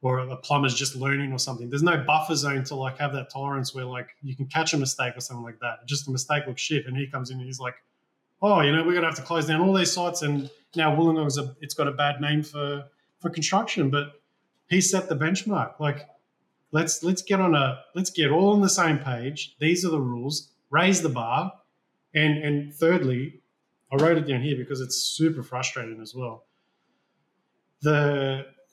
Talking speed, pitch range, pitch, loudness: 215 wpm, 130-160 Hz, 145 Hz, -25 LUFS